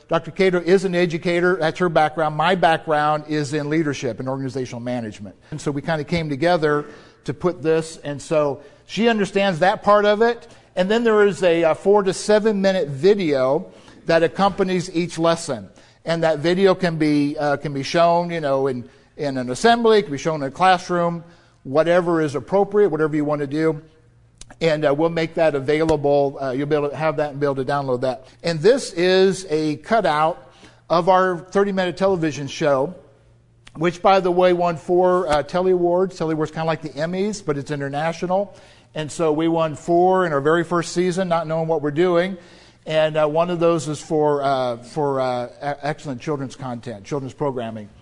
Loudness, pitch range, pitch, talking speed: -20 LUFS, 145-180 Hz, 160 Hz, 195 wpm